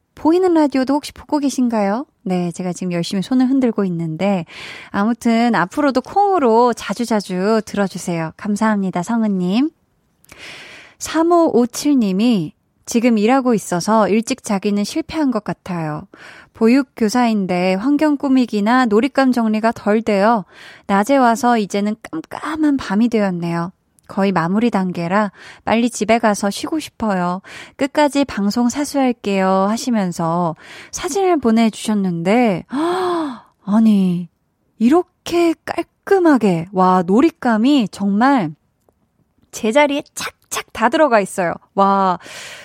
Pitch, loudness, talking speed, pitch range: 225 Hz, -17 LUFS, 270 characters per minute, 195-270 Hz